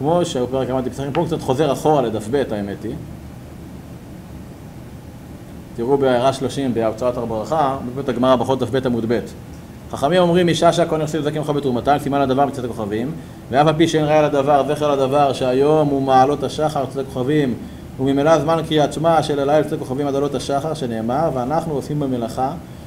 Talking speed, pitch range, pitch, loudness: 165 wpm, 125-150 Hz, 140 Hz, -18 LUFS